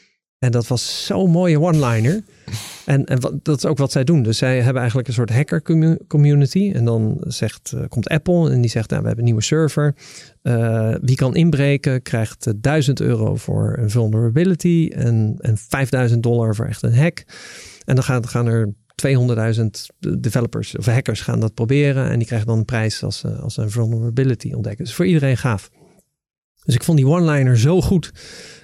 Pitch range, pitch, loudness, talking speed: 115-150 Hz, 130 Hz, -18 LUFS, 185 wpm